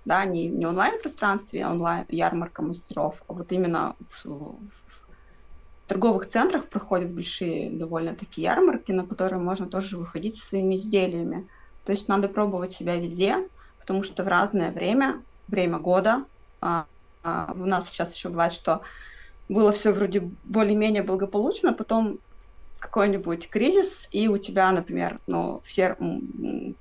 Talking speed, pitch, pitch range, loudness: 140 wpm, 190 Hz, 175-210 Hz, -26 LUFS